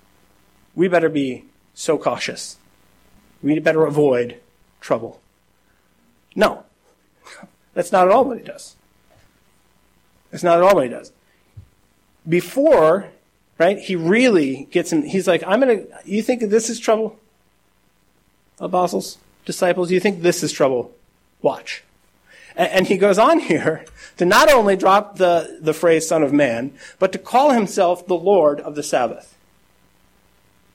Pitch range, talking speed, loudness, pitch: 165-215 Hz, 140 wpm, -18 LUFS, 185 Hz